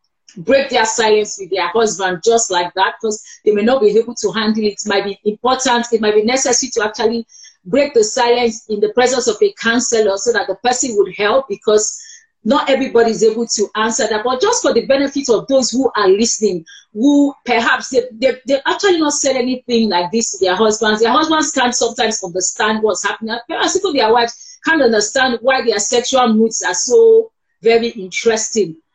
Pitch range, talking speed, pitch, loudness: 215-265 Hz, 200 wpm, 230 Hz, -15 LUFS